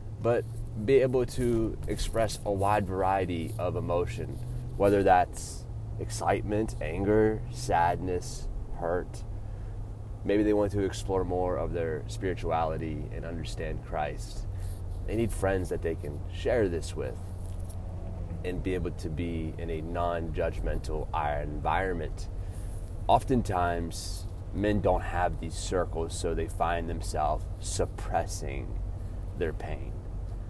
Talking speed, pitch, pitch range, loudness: 120 wpm, 95 Hz, 90-105 Hz, -31 LUFS